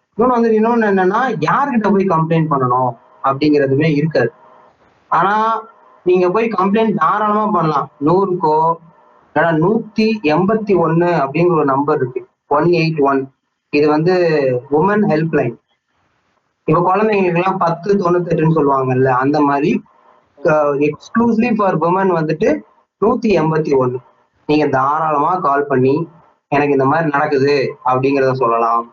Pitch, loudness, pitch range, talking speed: 160 Hz, -15 LUFS, 140-195 Hz, 115 wpm